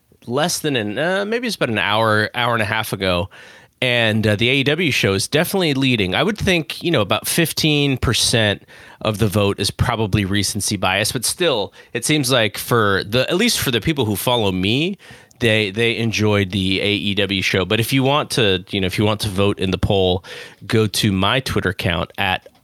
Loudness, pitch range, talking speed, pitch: -18 LUFS, 100-130 Hz, 210 wpm, 110 Hz